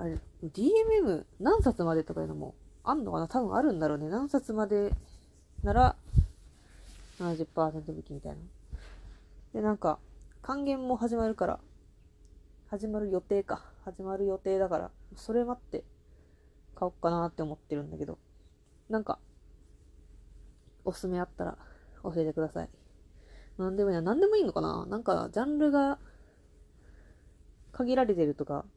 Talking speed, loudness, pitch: 280 characters per minute, -31 LUFS, 160 Hz